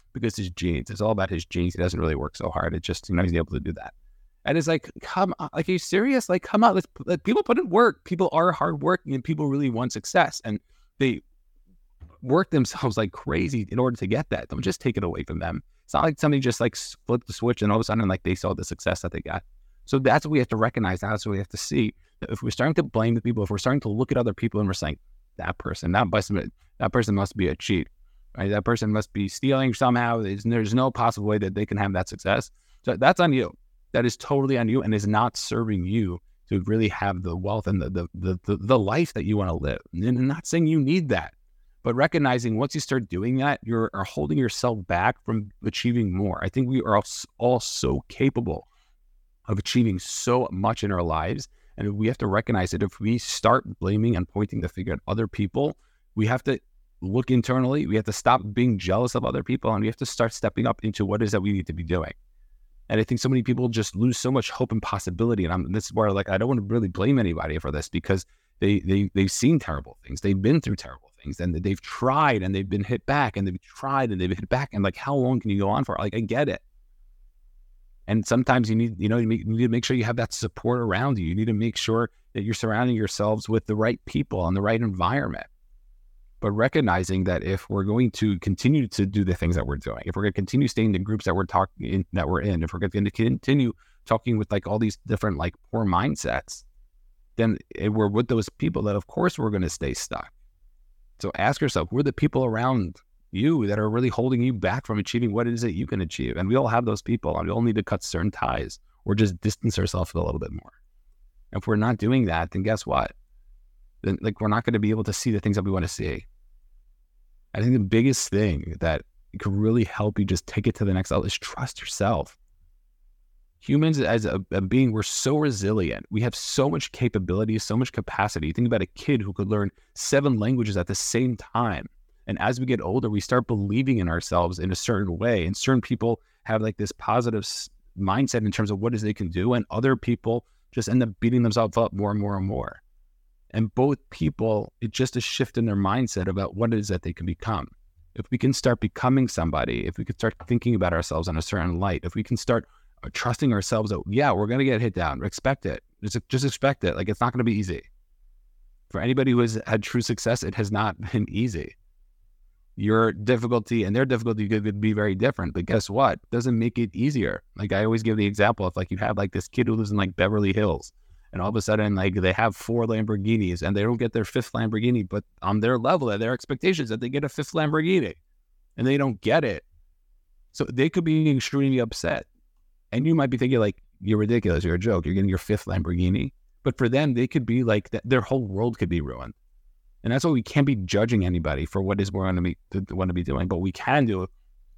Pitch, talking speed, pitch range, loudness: 105 Hz, 245 wpm, 95-120 Hz, -25 LUFS